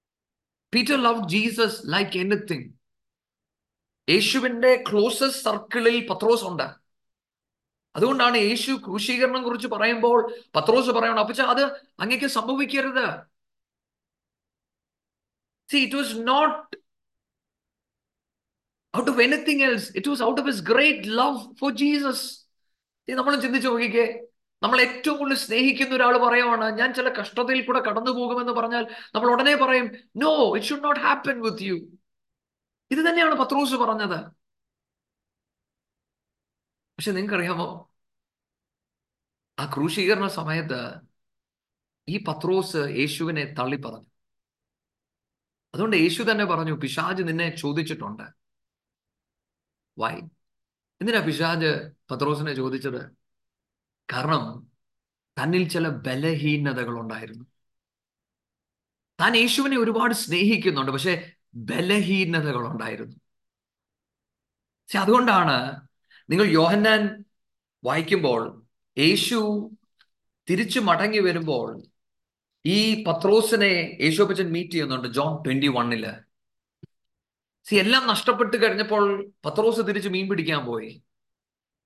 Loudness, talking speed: -23 LUFS, 90 wpm